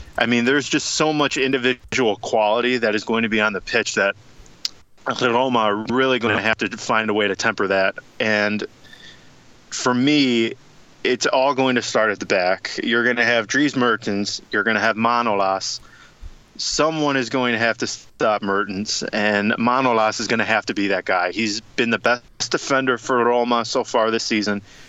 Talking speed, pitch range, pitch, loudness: 190 wpm, 105-125 Hz, 115 Hz, -20 LUFS